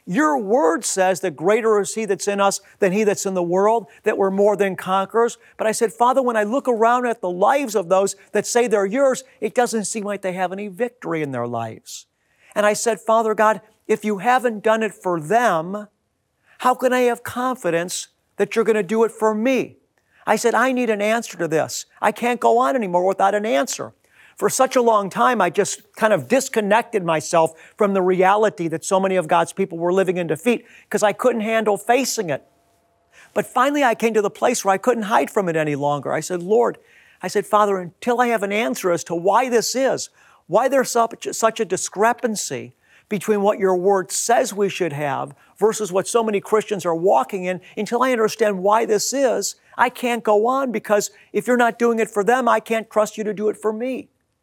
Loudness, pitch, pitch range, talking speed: -20 LUFS, 215 Hz, 195-235 Hz, 220 wpm